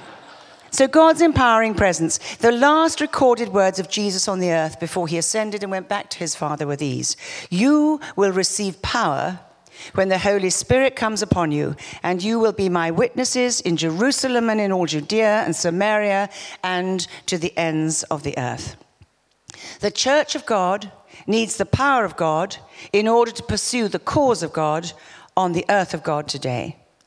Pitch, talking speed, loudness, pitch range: 195 Hz, 175 wpm, -20 LUFS, 165-225 Hz